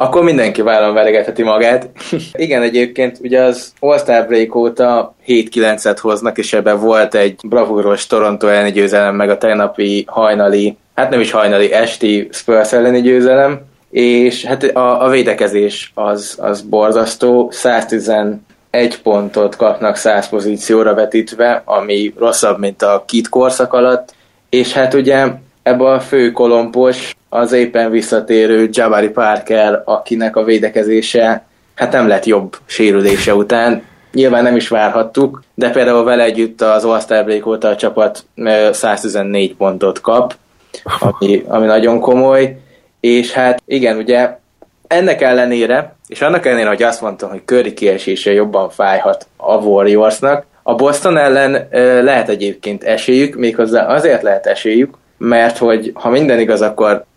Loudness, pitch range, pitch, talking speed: -12 LUFS, 105-125 Hz, 115 Hz, 140 wpm